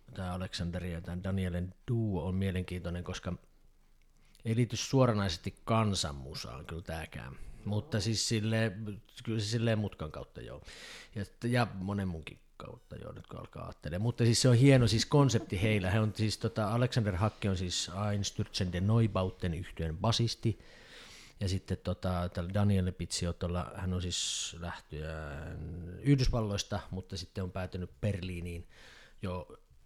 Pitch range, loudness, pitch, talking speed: 90-110 Hz, -33 LUFS, 95 Hz, 140 wpm